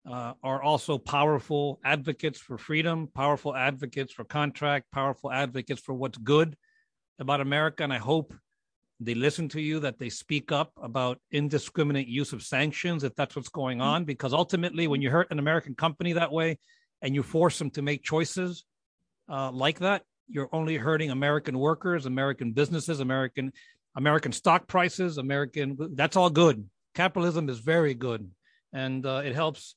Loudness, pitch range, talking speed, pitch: -28 LUFS, 135-160 Hz, 175 wpm, 145 Hz